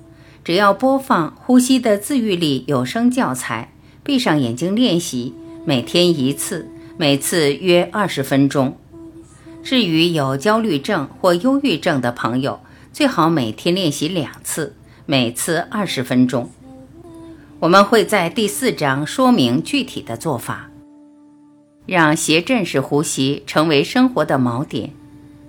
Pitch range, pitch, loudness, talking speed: 140-215 Hz, 160 Hz, -17 LUFS, 200 characters per minute